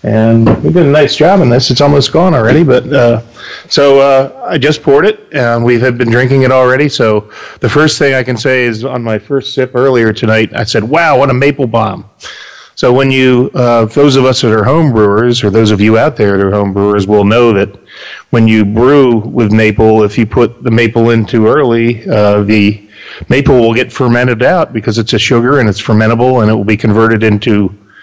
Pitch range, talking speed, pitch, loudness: 110-130 Hz, 225 wpm, 120 Hz, -8 LUFS